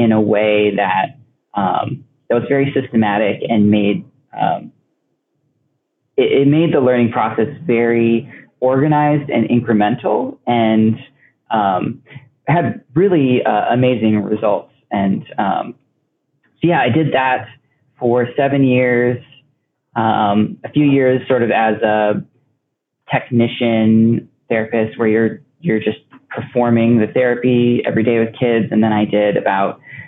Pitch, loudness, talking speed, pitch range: 120 Hz, -16 LUFS, 130 wpm, 110-130 Hz